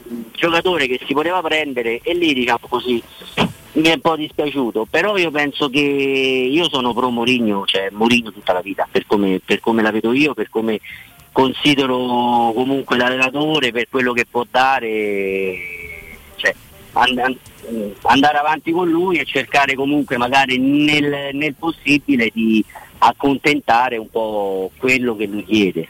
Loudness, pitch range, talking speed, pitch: -17 LUFS, 110-145 Hz, 155 wpm, 125 Hz